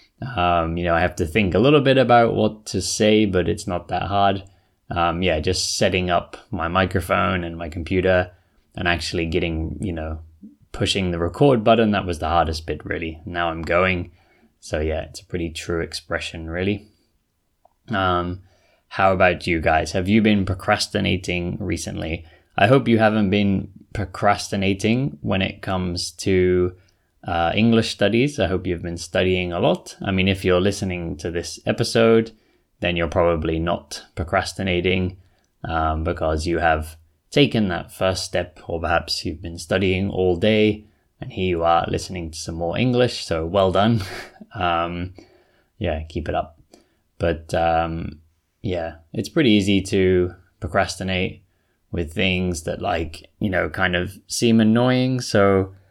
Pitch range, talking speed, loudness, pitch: 85-100 Hz, 160 wpm, -21 LUFS, 90 Hz